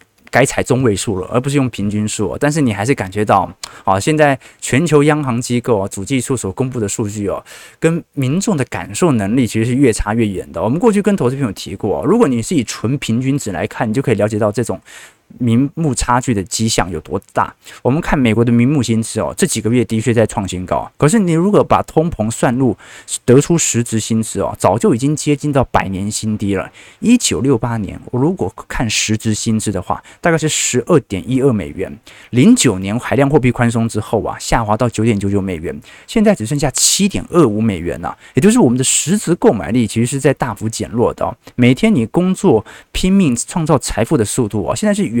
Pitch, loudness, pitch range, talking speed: 120 Hz, -15 LUFS, 105-145 Hz, 325 characters per minute